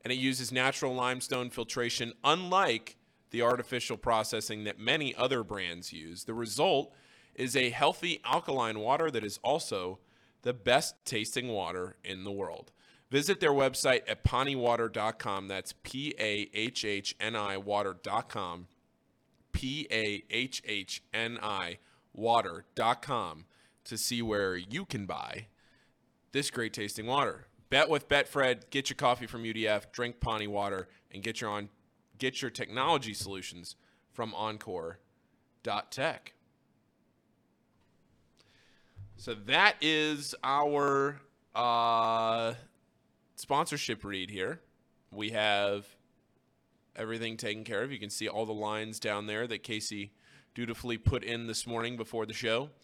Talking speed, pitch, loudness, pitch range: 120 wpm, 115 Hz, -32 LUFS, 105-125 Hz